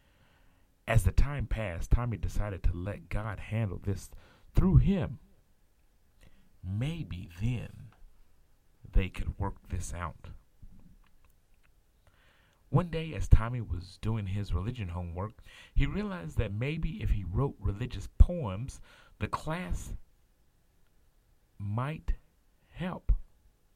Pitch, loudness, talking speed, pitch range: 100 Hz, -33 LUFS, 105 wpm, 90-115 Hz